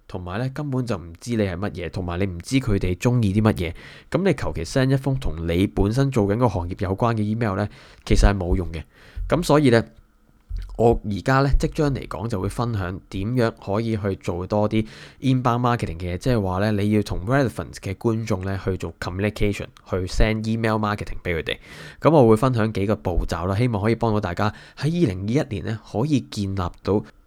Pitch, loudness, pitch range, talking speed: 105 Hz, -23 LUFS, 95-120 Hz, 405 characters per minute